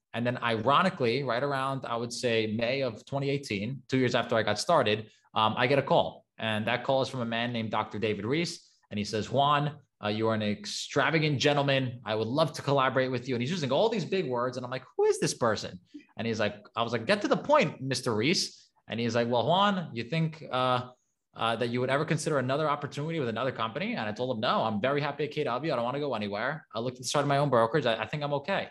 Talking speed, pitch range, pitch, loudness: 255 wpm, 115-145 Hz, 130 Hz, -29 LUFS